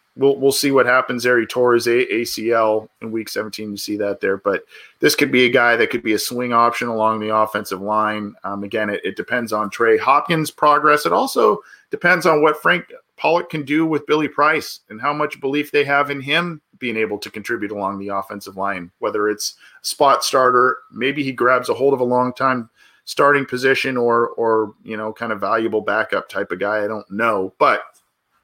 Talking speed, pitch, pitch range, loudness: 210 wpm, 115 Hz, 105-140 Hz, -18 LUFS